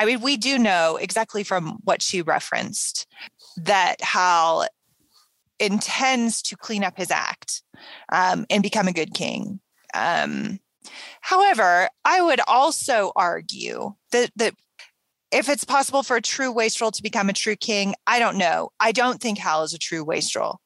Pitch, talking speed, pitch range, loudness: 220 Hz, 160 wpm, 190-245 Hz, -21 LUFS